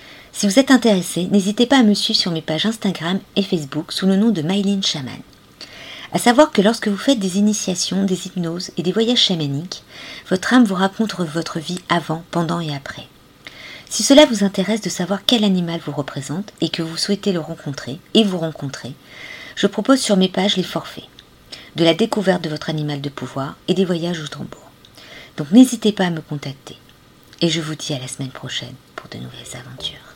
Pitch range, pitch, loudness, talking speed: 160-205 Hz, 185 Hz, -18 LUFS, 205 wpm